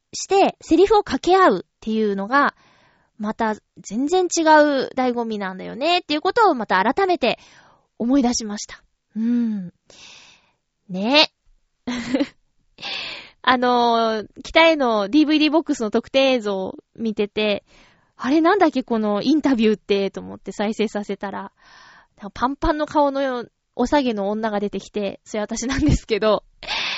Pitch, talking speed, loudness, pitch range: 240 Hz, 285 characters per minute, -20 LUFS, 210-295 Hz